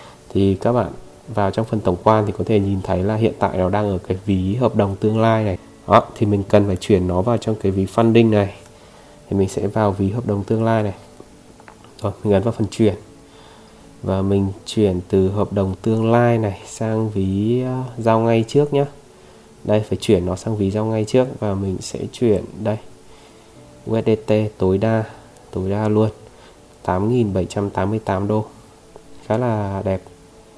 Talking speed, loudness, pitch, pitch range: 185 wpm, -19 LUFS, 105 Hz, 95-110 Hz